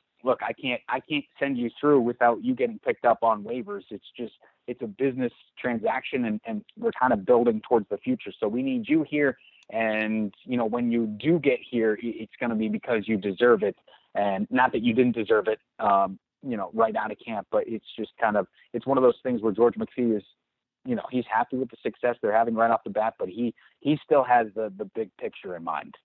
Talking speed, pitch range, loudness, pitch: 235 wpm, 110-145 Hz, -26 LUFS, 120 Hz